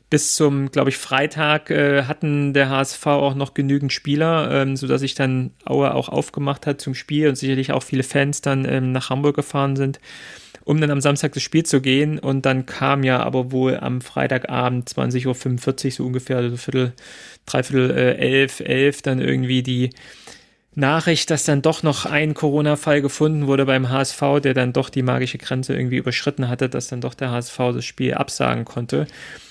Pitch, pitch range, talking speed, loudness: 135 Hz, 130-145 Hz, 190 wpm, -20 LUFS